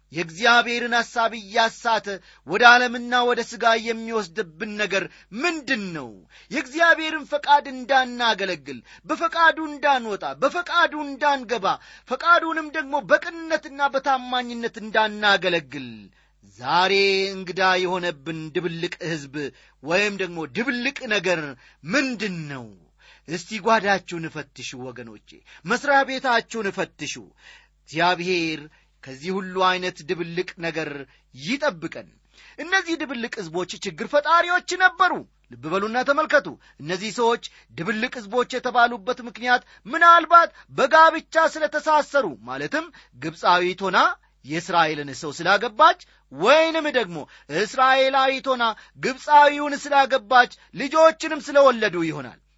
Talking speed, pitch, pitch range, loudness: 95 wpm, 230 Hz, 180-280 Hz, -21 LUFS